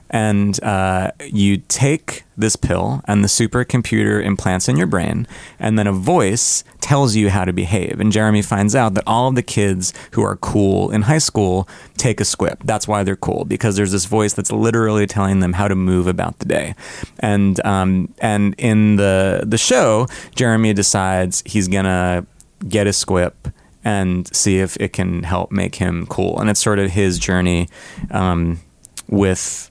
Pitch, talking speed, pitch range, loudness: 100 Hz, 180 wpm, 95-110 Hz, -17 LUFS